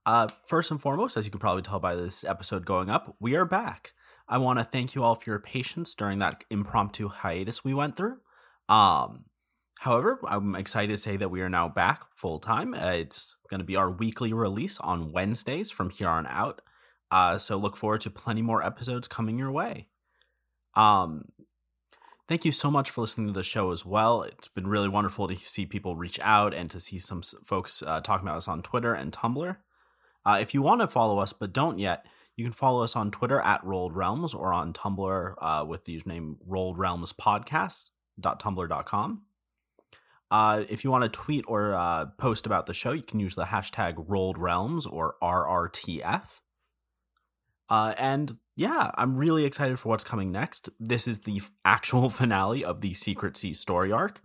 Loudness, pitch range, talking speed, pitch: -28 LUFS, 95-120 Hz, 195 wpm, 105 Hz